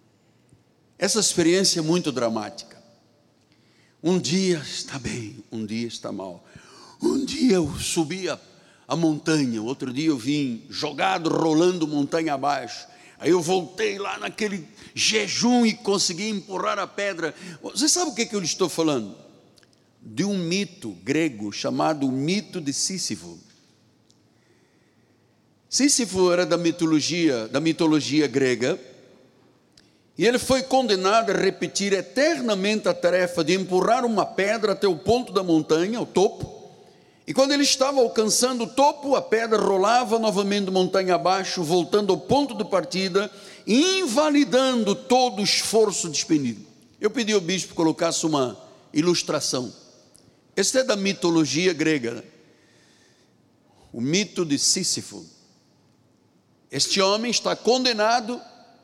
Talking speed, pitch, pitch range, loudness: 130 wpm, 185 Hz, 160-215 Hz, -22 LUFS